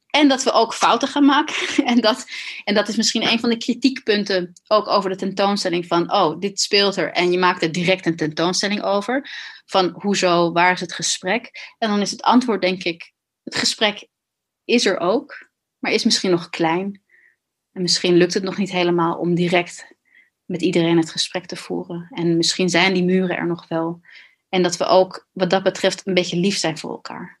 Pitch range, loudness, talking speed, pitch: 175-215 Hz, -19 LUFS, 205 wpm, 185 Hz